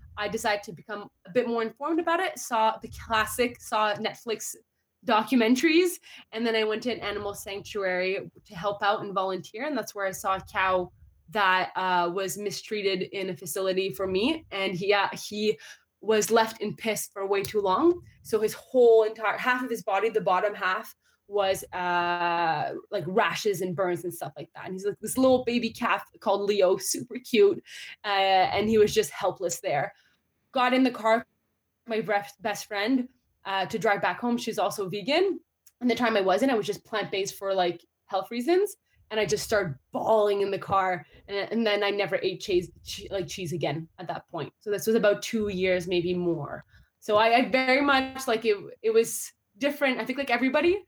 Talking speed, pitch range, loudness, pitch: 195 wpm, 190-230 Hz, -27 LUFS, 205 Hz